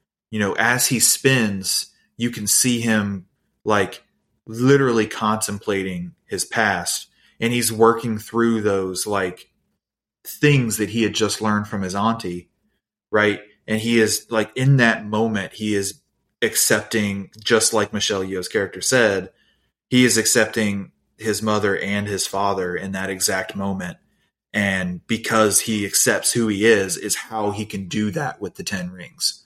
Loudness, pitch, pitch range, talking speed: -20 LUFS, 110 Hz, 100-115 Hz, 155 wpm